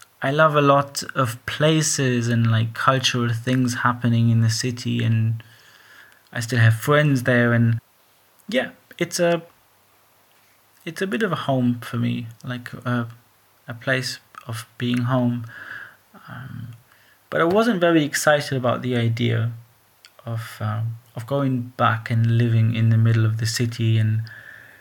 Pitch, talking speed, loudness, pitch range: 120 Hz, 150 wpm, -21 LUFS, 115-130 Hz